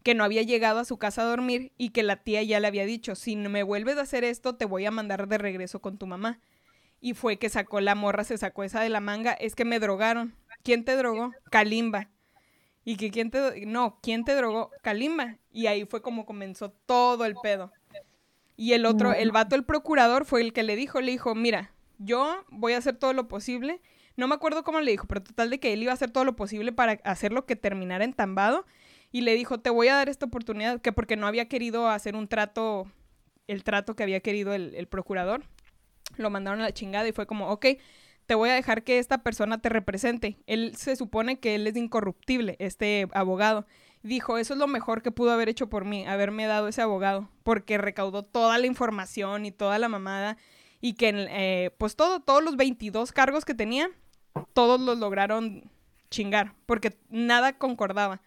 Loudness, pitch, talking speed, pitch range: -27 LUFS, 225 Hz, 215 wpm, 205-245 Hz